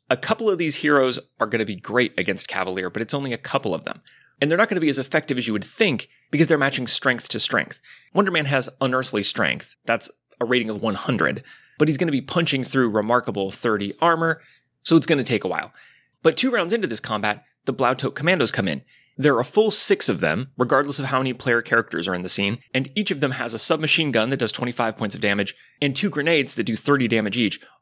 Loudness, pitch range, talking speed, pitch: -22 LUFS, 115-160 Hz, 235 wpm, 135 Hz